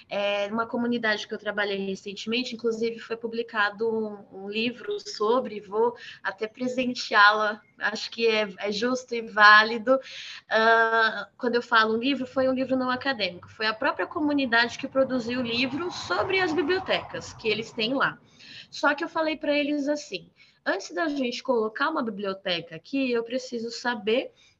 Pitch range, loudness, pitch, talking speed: 215-265 Hz, -25 LUFS, 235 Hz, 165 wpm